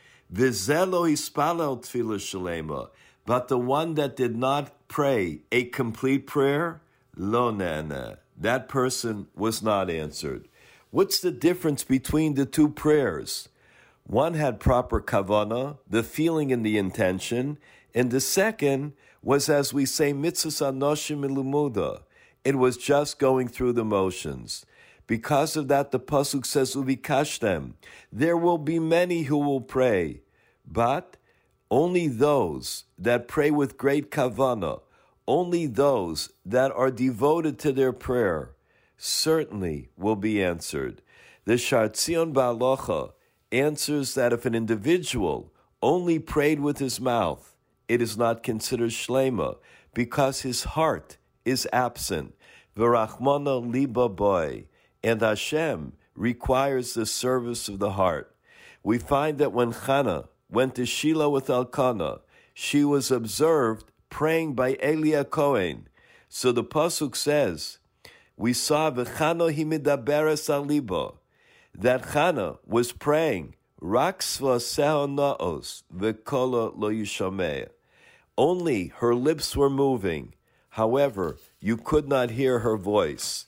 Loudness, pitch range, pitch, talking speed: -25 LUFS, 120-150 Hz, 135 Hz, 115 wpm